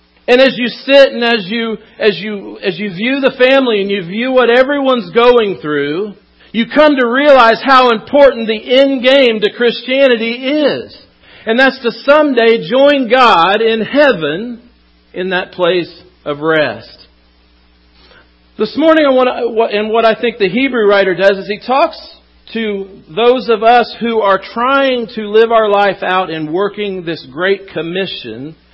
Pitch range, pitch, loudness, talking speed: 195-255 Hz, 225 Hz, -11 LUFS, 165 wpm